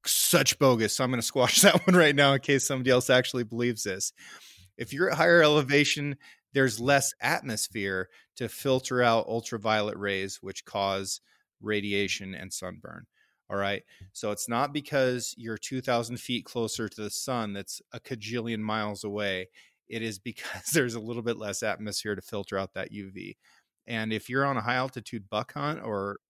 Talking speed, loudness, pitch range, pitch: 180 wpm, -27 LUFS, 105-130 Hz, 115 Hz